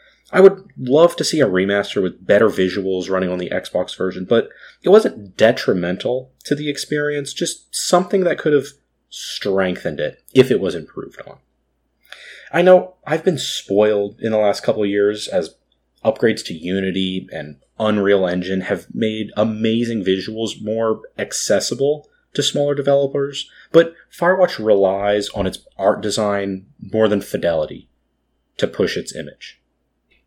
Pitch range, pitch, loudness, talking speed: 95-145 Hz, 110 Hz, -18 LUFS, 150 wpm